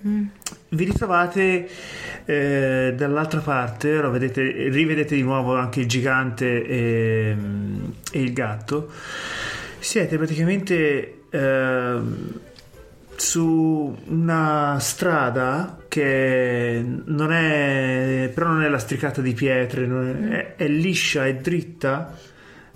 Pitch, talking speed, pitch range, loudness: 145 Hz, 100 wpm, 130-165 Hz, -22 LUFS